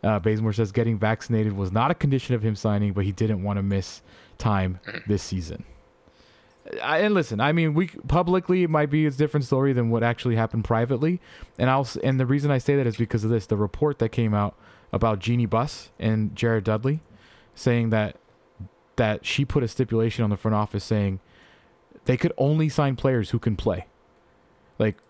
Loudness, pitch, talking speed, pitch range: -24 LUFS, 115 Hz, 200 wpm, 105-135 Hz